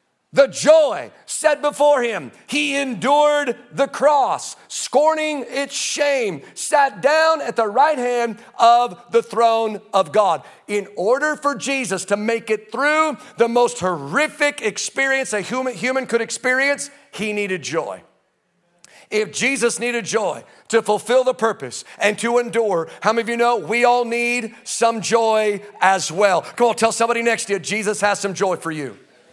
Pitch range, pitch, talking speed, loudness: 210-275 Hz, 235 Hz, 160 wpm, -19 LUFS